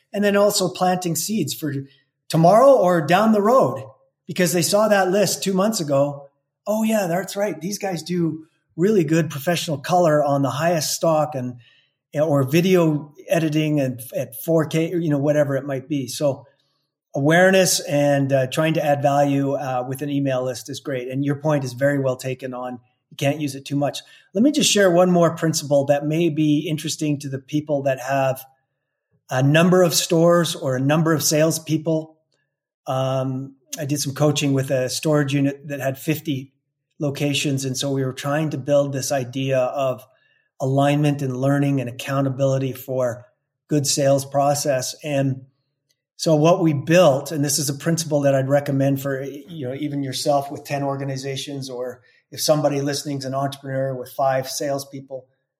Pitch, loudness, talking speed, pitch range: 145 Hz, -20 LUFS, 180 wpm, 135-160 Hz